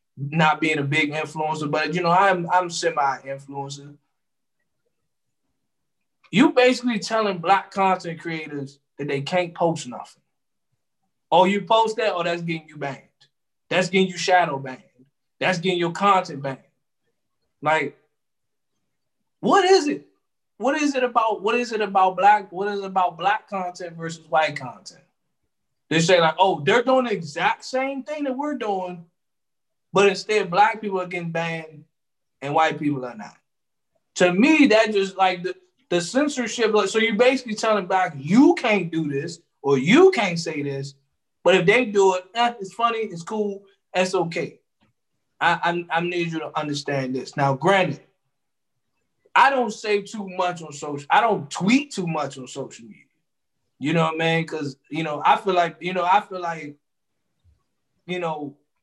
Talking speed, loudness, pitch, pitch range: 170 wpm, -21 LUFS, 180 Hz, 155-210 Hz